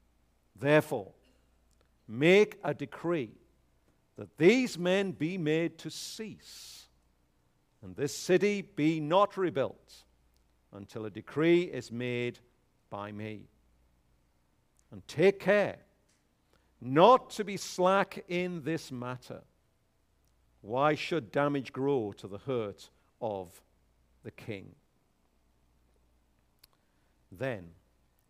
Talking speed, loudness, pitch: 95 wpm, -30 LUFS, 105 Hz